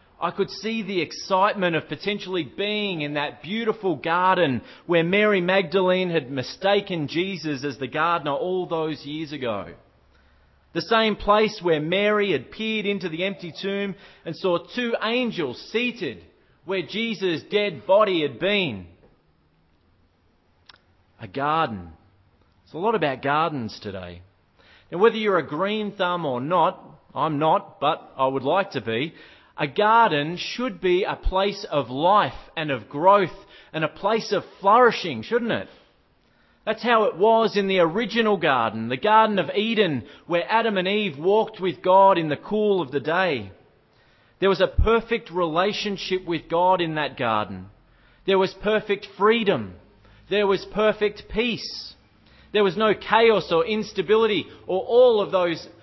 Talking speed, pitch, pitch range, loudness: 155 wpm, 185 Hz, 145-205 Hz, -23 LUFS